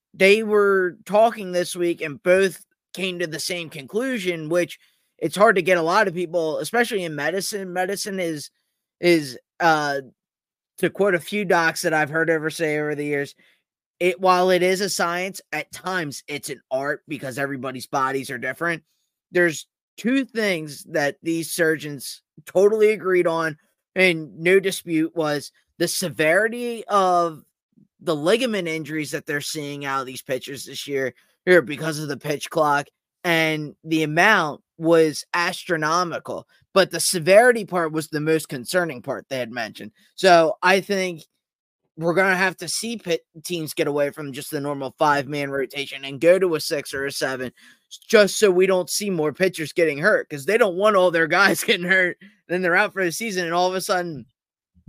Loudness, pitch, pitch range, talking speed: -21 LUFS, 170 Hz, 150-185 Hz, 180 wpm